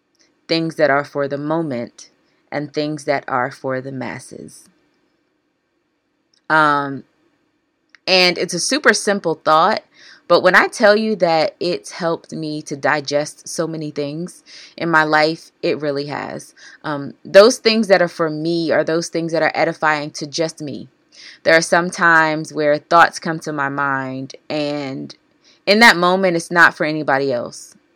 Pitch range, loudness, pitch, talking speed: 150-200 Hz, -17 LUFS, 165 Hz, 160 wpm